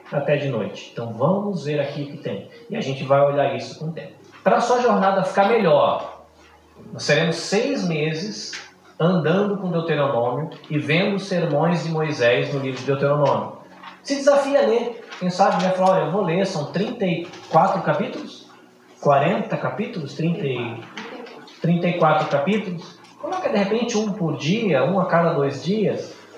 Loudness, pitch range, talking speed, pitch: -21 LUFS, 145-195 Hz, 160 wpm, 170 Hz